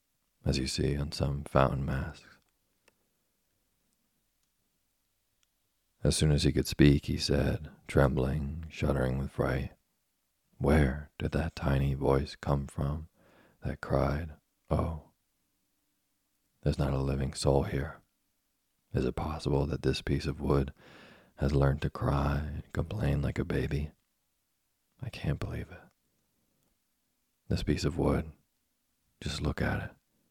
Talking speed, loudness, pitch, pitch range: 125 wpm, -31 LUFS, 70 Hz, 70-75 Hz